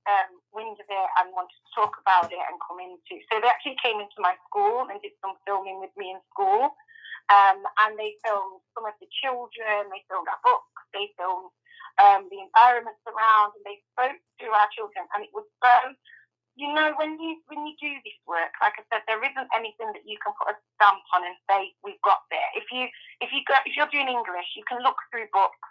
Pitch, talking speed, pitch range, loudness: 220 Hz, 225 wpm, 200-280 Hz, -24 LUFS